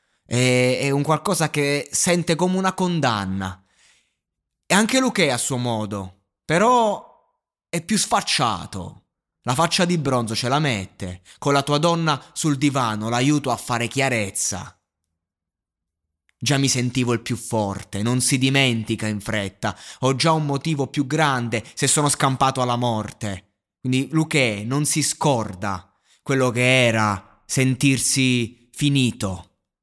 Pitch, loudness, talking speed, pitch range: 125 Hz, -21 LUFS, 135 wpm, 105-145 Hz